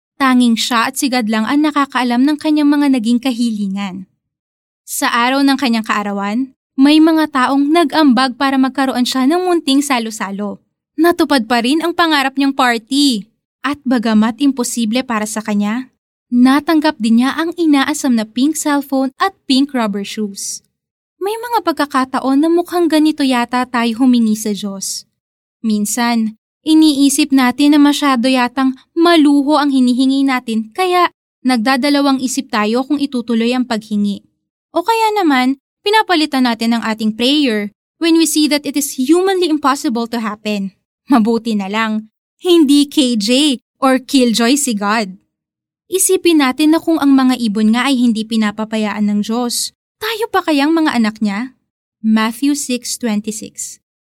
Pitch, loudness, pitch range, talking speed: 260 Hz, -14 LUFS, 230-290 Hz, 145 wpm